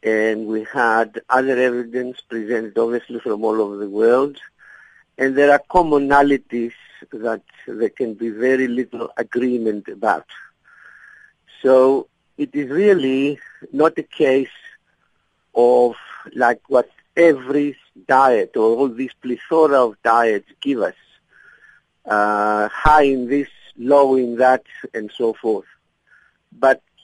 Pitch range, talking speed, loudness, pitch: 115-140 Hz, 120 wpm, -18 LUFS, 125 Hz